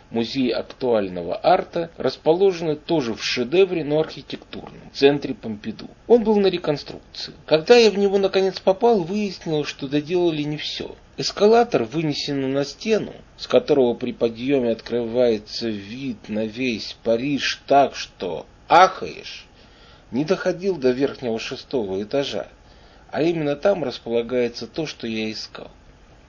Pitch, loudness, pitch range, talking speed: 140 Hz, -21 LUFS, 120-180 Hz, 130 wpm